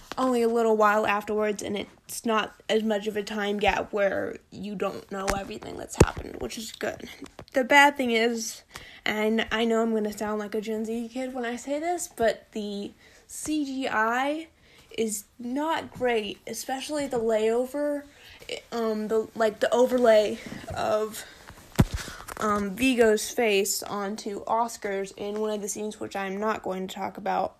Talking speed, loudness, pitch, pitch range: 165 wpm, -27 LUFS, 220 Hz, 210-245 Hz